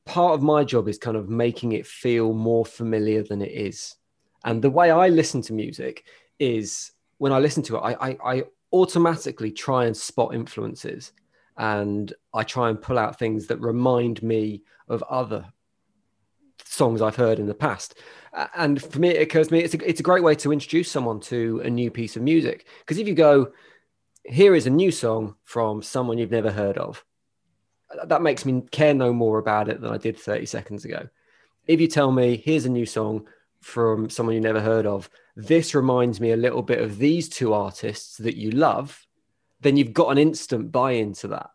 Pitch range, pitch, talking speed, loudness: 110-150 Hz, 120 Hz, 200 wpm, -22 LUFS